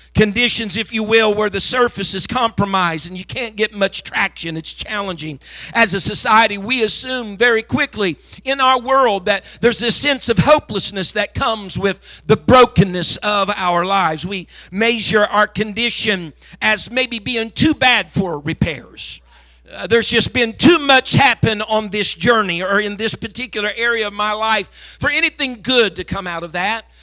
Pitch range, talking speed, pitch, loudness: 195-235 Hz, 175 wpm, 215 Hz, -16 LUFS